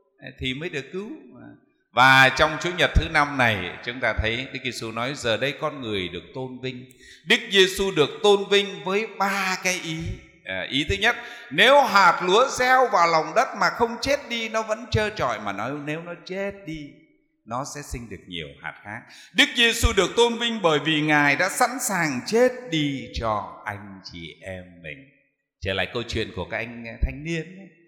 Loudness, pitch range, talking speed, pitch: -22 LUFS, 130-205 Hz, 200 wpm, 155 Hz